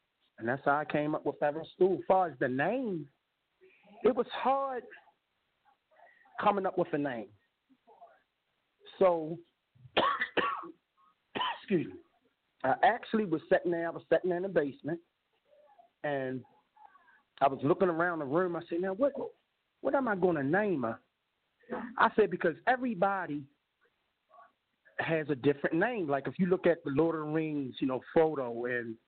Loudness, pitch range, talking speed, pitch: -31 LUFS, 150-215 Hz, 155 wpm, 170 Hz